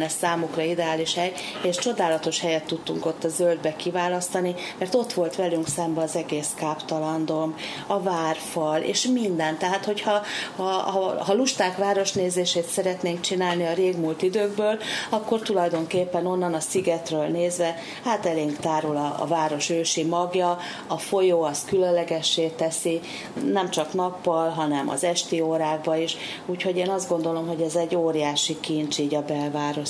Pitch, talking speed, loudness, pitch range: 170 Hz, 150 wpm, -25 LUFS, 160-185 Hz